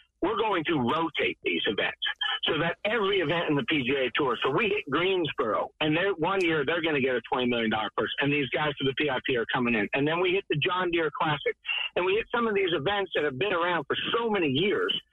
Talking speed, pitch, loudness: 240 wpm, 185 Hz, -27 LUFS